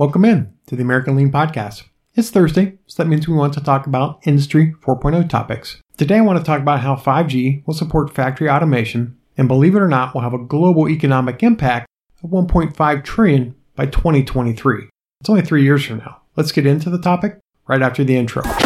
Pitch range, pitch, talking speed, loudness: 130-165 Hz, 145 Hz, 205 wpm, -16 LUFS